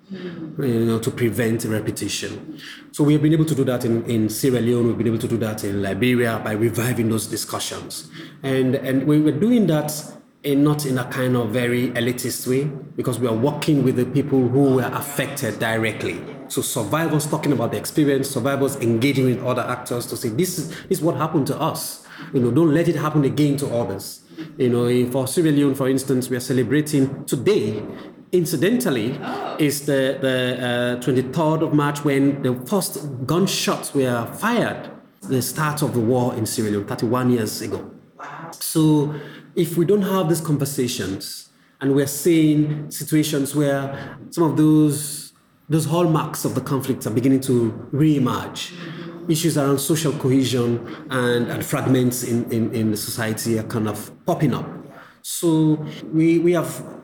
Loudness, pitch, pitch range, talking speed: -21 LUFS, 135 Hz, 120-155 Hz, 175 wpm